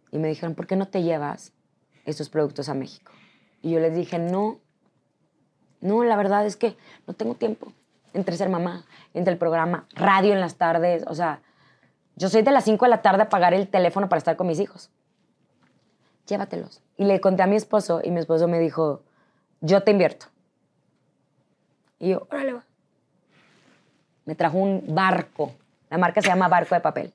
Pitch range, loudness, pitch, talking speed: 165-200 Hz, -23 LUFS, 180 Hz, 185 wpm